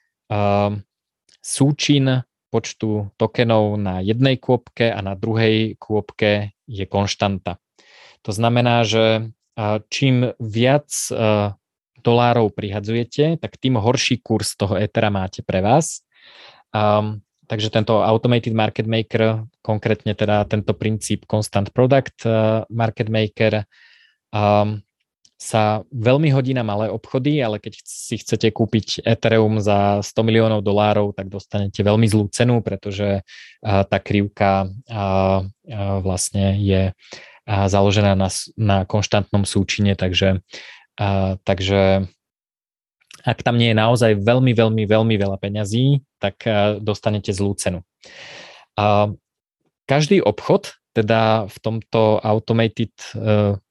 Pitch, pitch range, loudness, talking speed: 110 Hz, 100-115 Hz, -19 LUFS, 115 wpm